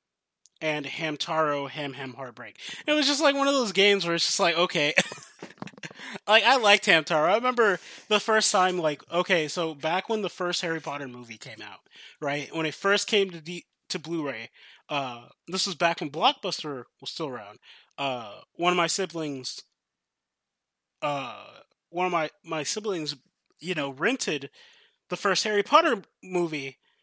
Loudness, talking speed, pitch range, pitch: -25 LUFS, 170 wpm, 150-205 Hz, 175 Hz